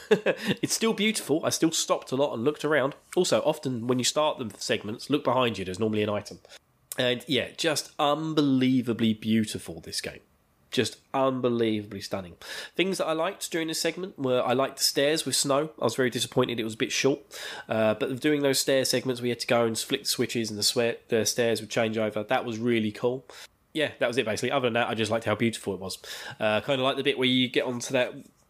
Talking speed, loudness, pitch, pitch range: 230 wpm, -27 LUFS, 125 Hz, 115-140 Hz